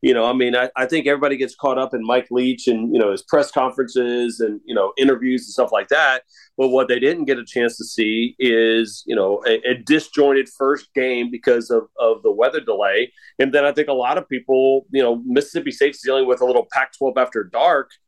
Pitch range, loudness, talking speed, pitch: 125-145 Hz, -18 LUFS, 235 wpm, 130 Hz